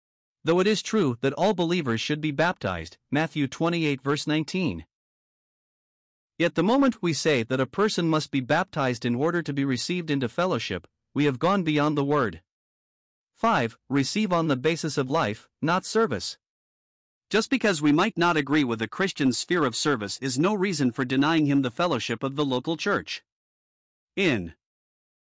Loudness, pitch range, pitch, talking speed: -25 LUFS, 130-175 Hz, 150 Hz, 170 wpm